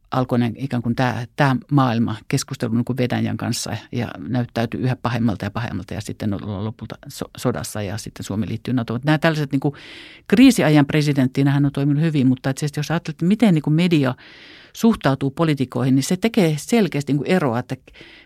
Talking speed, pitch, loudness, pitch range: 175 wpm, 130 Hz, -20 LUFS, 120-150 Hz